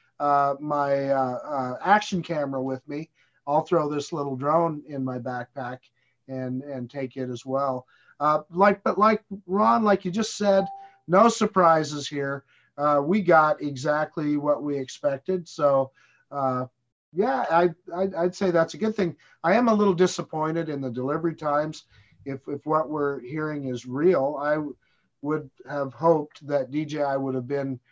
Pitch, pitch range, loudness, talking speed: 150 Hz, 135-170 Hz, -25 LUFS, 170 wpm